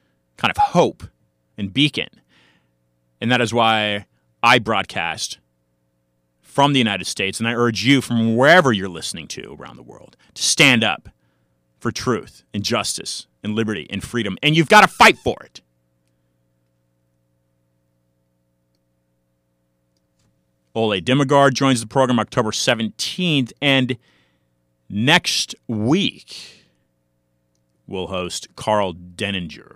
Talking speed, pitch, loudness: 120 wpm, 80 Hz, -18 LUFS